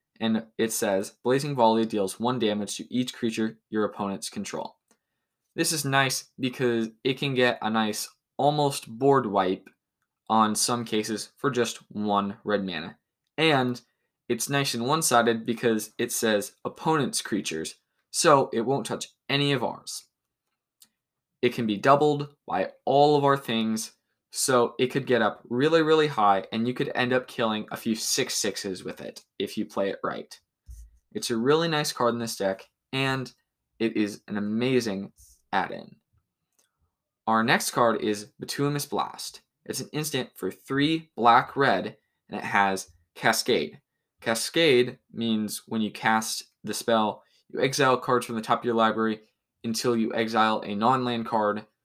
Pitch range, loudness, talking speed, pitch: 110-130 Hz, -26 LUFS, 165 wpm, 115 Hz